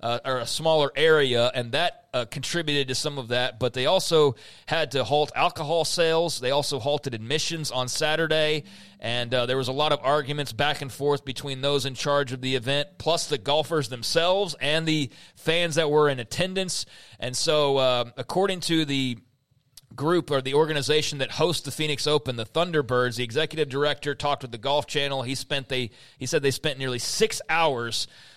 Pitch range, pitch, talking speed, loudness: 130-155 Hz, 145 Hz, 195 wpm, -25 LUFS